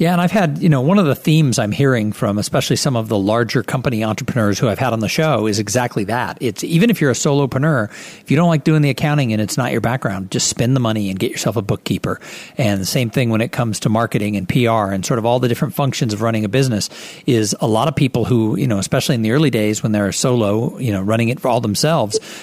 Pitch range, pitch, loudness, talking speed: 110-145 Hz, 125 Hz, -17 LUFS, 270 wpm